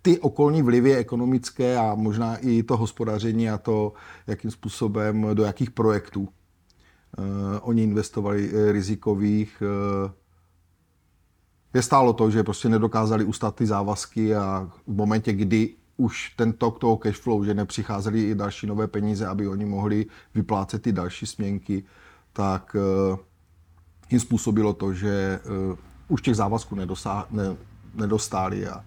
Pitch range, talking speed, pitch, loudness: 95-110 Hz, 135 wpm, 105 Hz, -25 LUFS